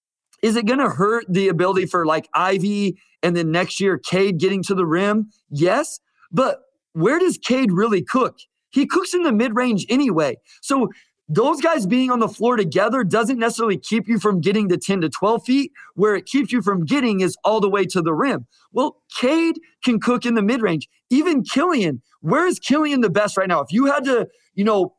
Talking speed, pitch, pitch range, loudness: 205 wpm, 220 Hz, 190-265 Hz, -19 LUFS